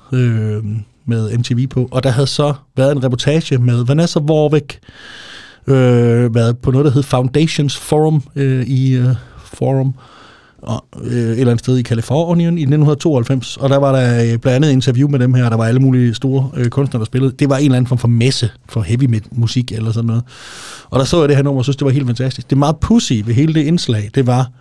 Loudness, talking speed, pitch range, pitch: -14 LUFS, 230 wpm, 120-140 Hz, 130 Hz